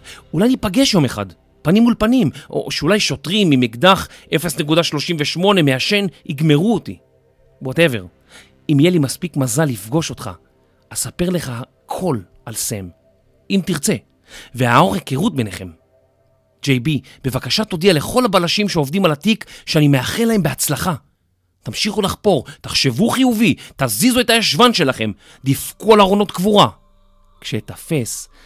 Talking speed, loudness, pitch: 125 wpm, -16 LUFS, 150 Hz